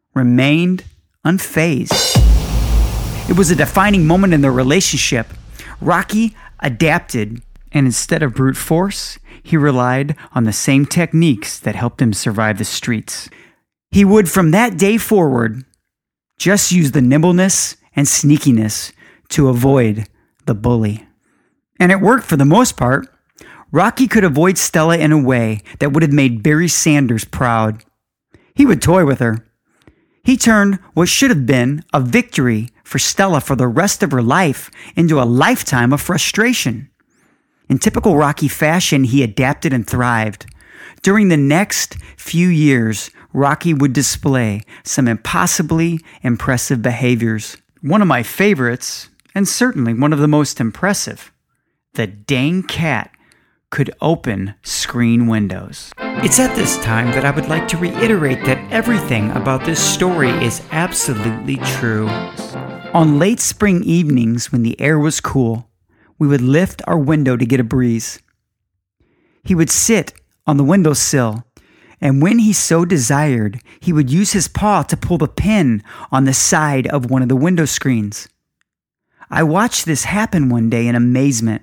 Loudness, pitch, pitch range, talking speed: -14 LUFS, 140 Hz, 120-170 Hz, 150 wpm